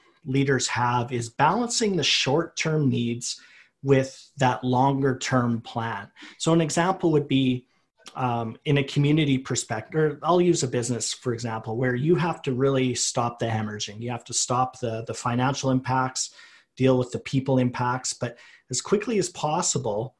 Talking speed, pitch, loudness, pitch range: 165 wpm, 130 Hz, -25 LUFS, 120-140 Hz